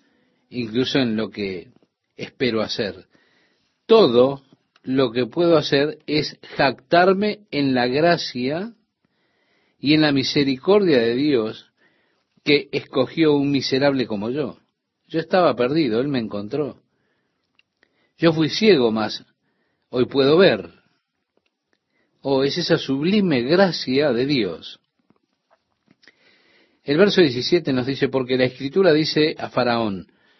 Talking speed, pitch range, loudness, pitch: 115 wpm, 125-165 Hz, -20 LUFS, 140 Hz